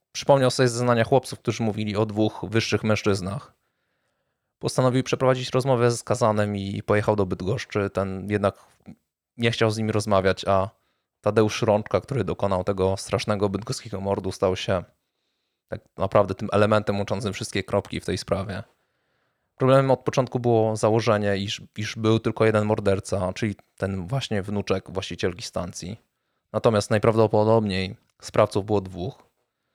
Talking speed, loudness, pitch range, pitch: 140 wpm, -24 LUFS, 100-115 Hz, 105 Hz